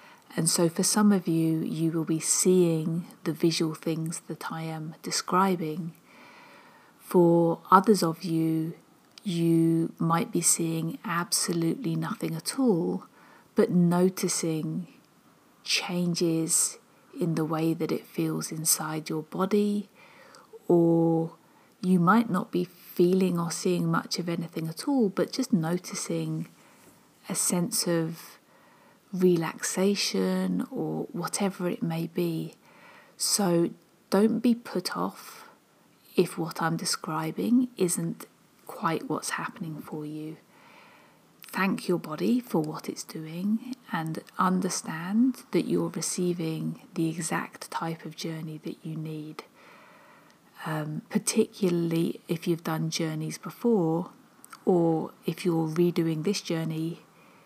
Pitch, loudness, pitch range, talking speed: 170 Hz, -27 LUFS, 160-195 Hz, 120 wpm